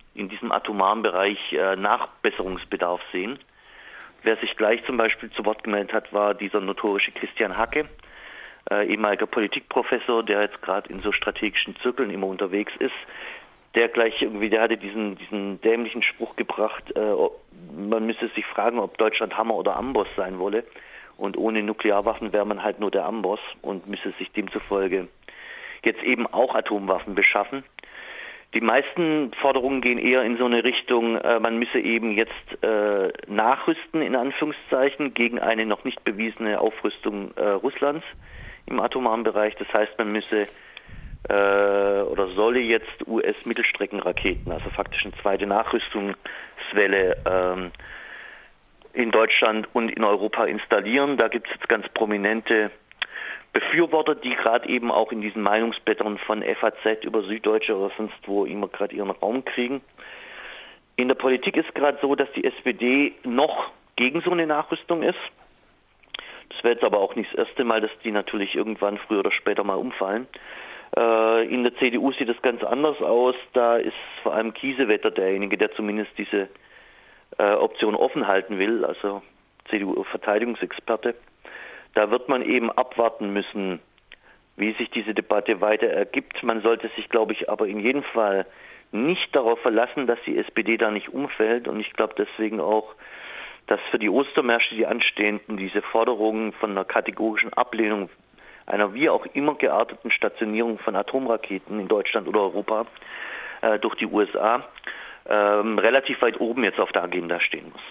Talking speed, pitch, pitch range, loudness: 155 wpm, 110 Hz, 105-125 Hz, -24 LUFS